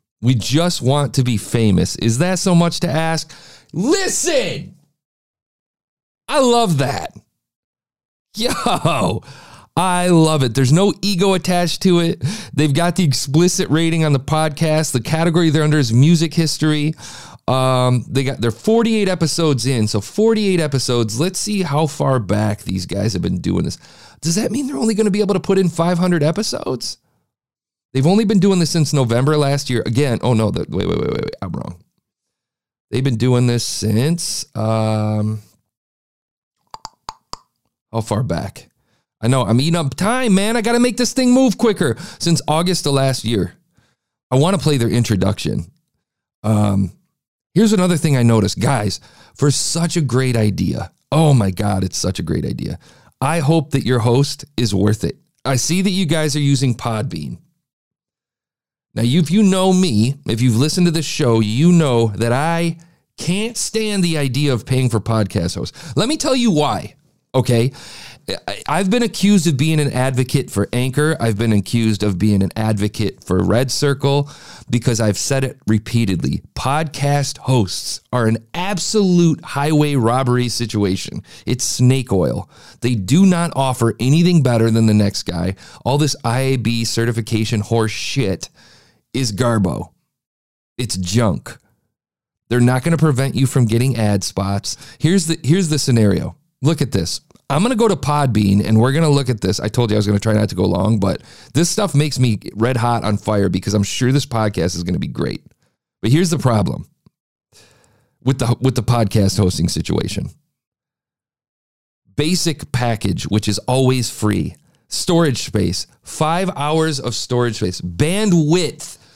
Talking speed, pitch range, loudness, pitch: 170 wpm, 110-165 Hz, -17 LUFS, 130 Hz